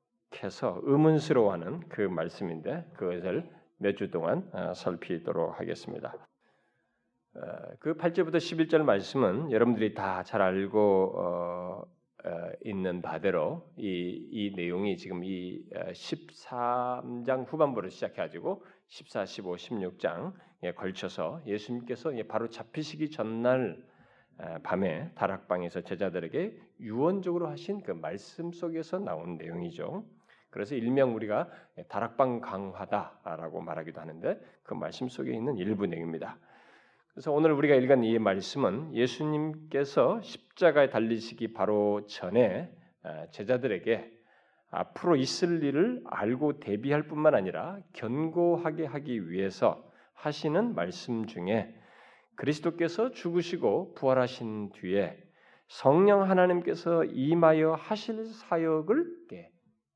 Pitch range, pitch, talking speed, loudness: 100-160 Hz, 125 Hz, 265 characters per minute, -31 LUFS